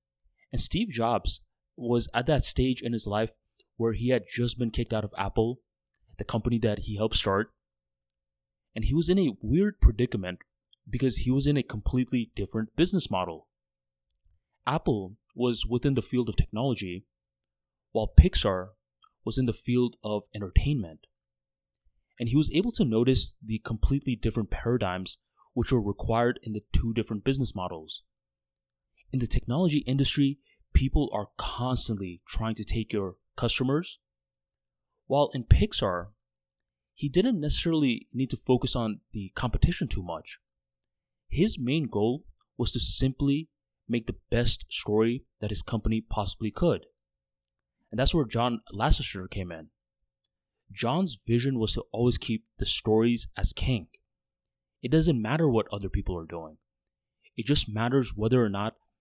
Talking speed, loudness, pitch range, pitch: 150 wpm, -28 LUFS, 85-125 Hz, 110 Hz